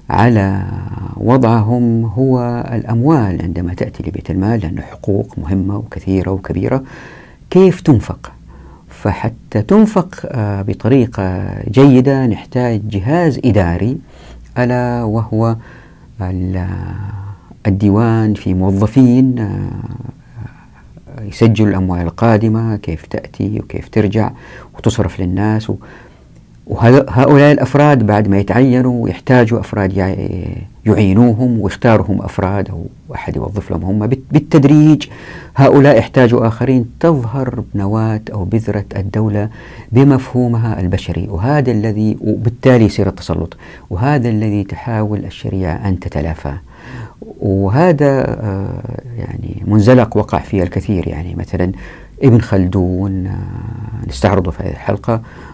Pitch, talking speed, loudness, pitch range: 110 Hz, 95 wpm, -14 LUFS, 95-125 Hz